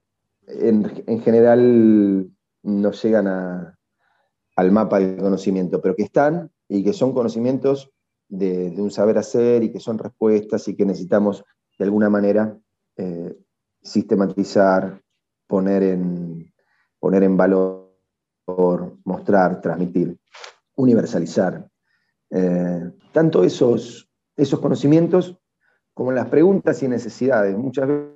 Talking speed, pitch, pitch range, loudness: 115 wpm, 100 Hz, 95-115 Hz, -19 LUFS